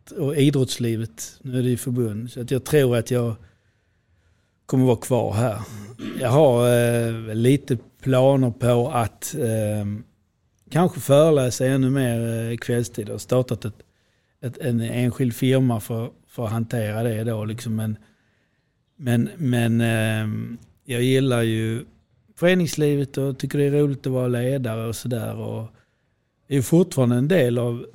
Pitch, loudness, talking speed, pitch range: 120 Hz, -22 LUFS, 155 wpm, 110-130 Hz